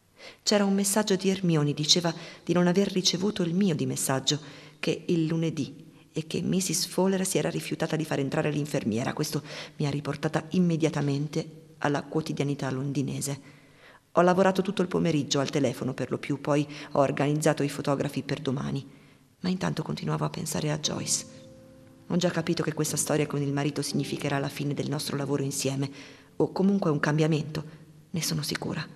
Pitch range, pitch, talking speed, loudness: 140-165 Hz, 150 Hz, 170 wpm, -28 LUFS